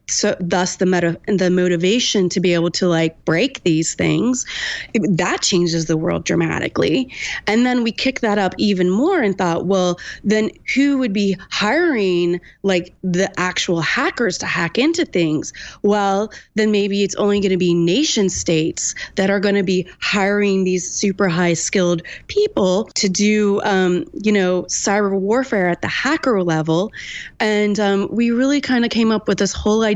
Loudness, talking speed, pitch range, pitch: -18 LUFS, 175 wpm, 180-215 Hz, 200 Hz